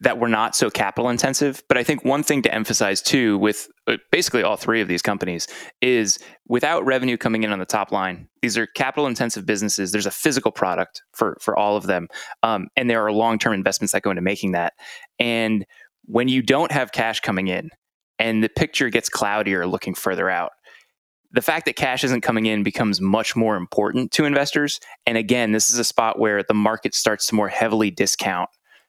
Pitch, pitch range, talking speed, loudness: 110 Hz, 105-125 Hz, 205 wpm, -21 LUFS